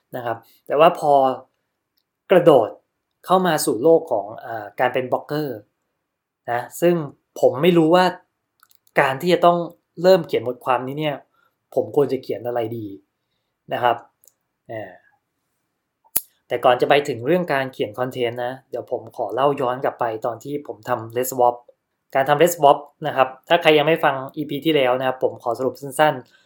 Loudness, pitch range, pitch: -20 LUFS, 125-165 Hz, 140 Hz